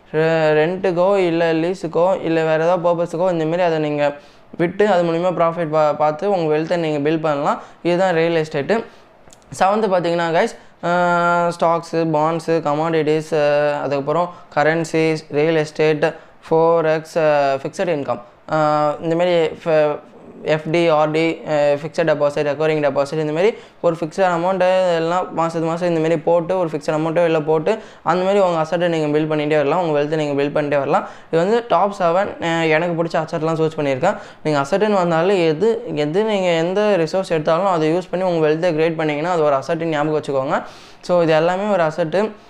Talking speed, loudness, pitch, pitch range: 150 wpm, -18 LUFS, 165 Hz, 155-175 Hz